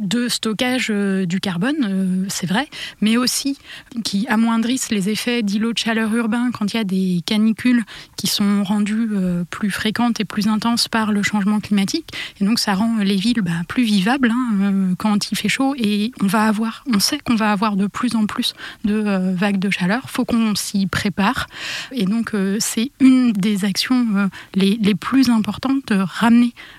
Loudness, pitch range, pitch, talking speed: -19 LUFS, 200-235 Hz, 215 Hz, 200 wpm